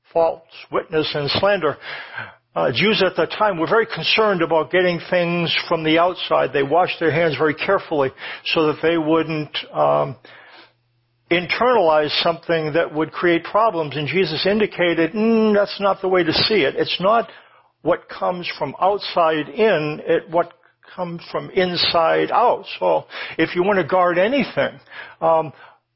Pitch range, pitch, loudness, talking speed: 155-185 Hz, 170 Hz, -19 LUFS, 155 wpm